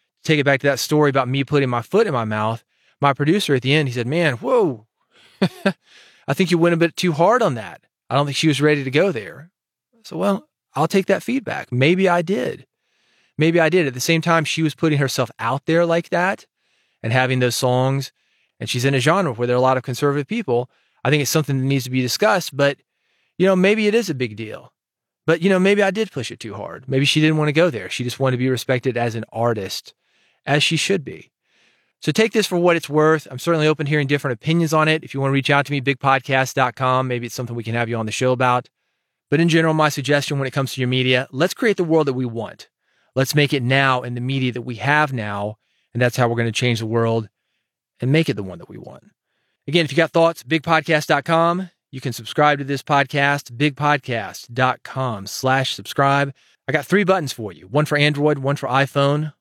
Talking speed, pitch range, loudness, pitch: 240 wpm, 125-160 Hz, -19 LUFS, 140 Hz